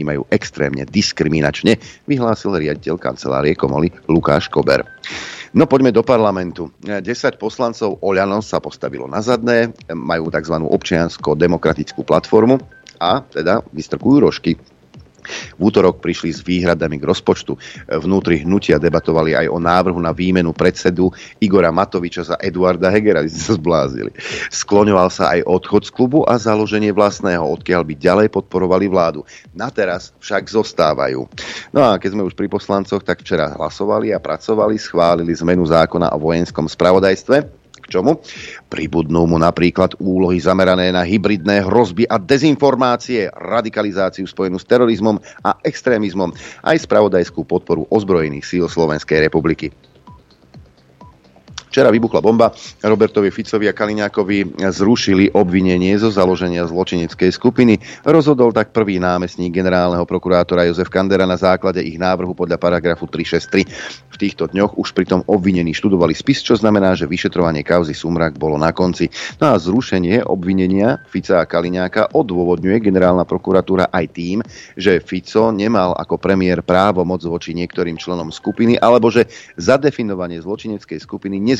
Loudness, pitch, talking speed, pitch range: -16 LUFS, 95 Hz, 135 wpm, 85-105 Hz